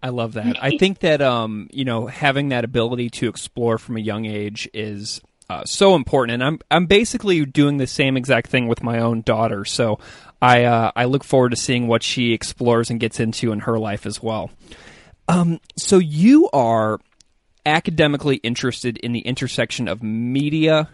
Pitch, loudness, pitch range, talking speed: 120 Hz, -19 LUFS, 115-140 Hz, 185 wpm